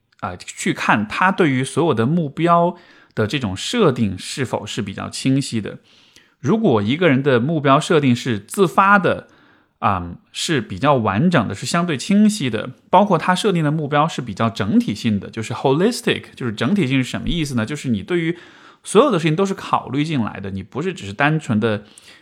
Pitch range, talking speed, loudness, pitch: 115-170 Hz, 310 characters per minute, -19 LUFS, 140 Hz